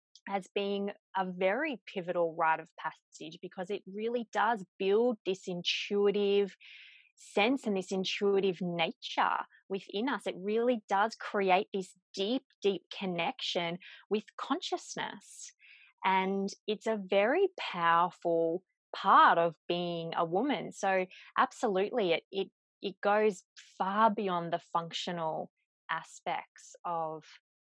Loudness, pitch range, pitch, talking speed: -32 LUFS, 180-215 Hz, 195 Hz, 115 wpm